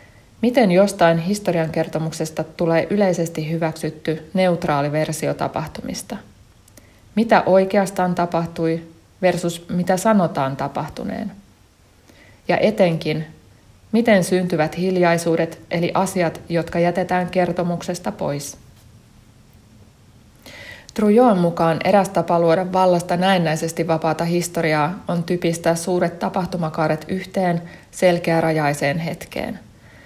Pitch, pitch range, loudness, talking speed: 170 Hz, 155-185 Hz, -20 LUFS, 85 wpm